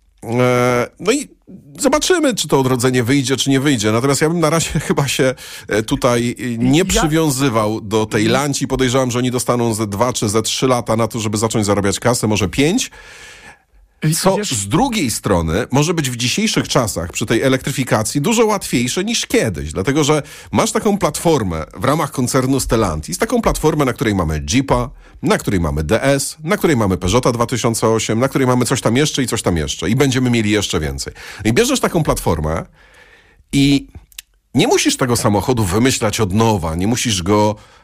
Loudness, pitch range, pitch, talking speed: -16 LUFS, 110-145 Hz, 125 Hz, 175 wpm